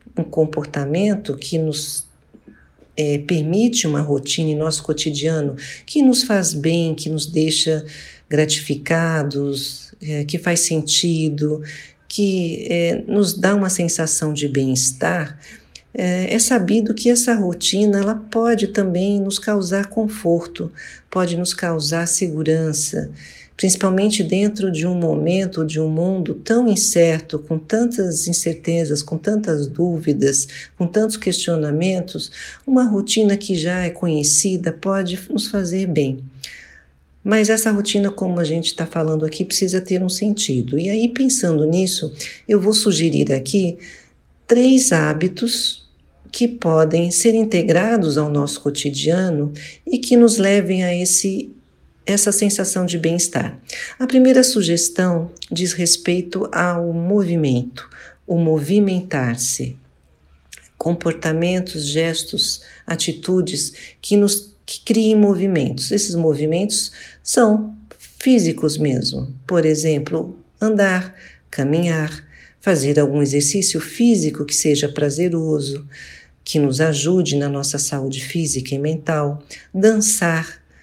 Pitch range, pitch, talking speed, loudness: 155-200 Hz, 170 Hz, 120 wpm, -18 LUFS